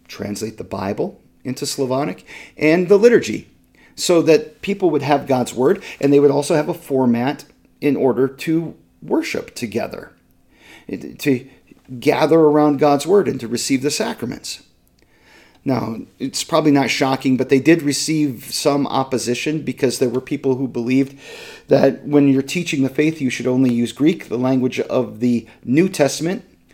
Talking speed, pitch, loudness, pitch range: 160 wpm, 140 Hz, -18 LUFS, 130-155 Hz